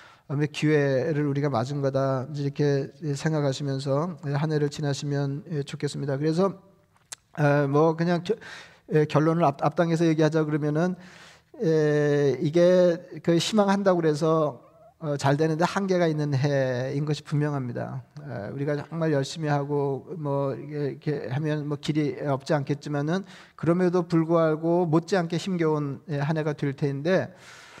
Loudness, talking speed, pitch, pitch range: -25 LUFS, 275 characters per minute, 150 Hz, 140-165 Hz